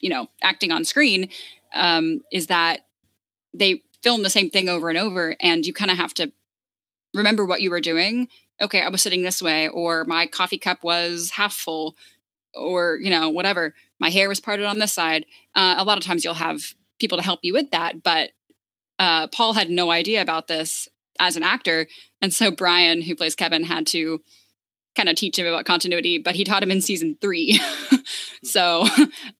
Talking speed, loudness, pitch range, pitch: 200 wpm, -20 LUFS, 165-200 Hz, 175 Hz